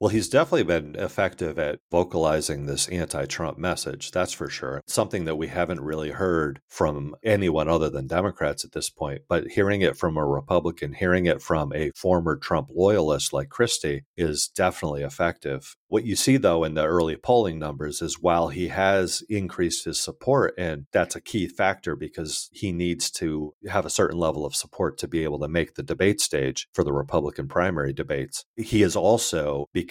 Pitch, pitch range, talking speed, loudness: 80 Hz, 75-90 Hz, 185 wpm, -25 LUFS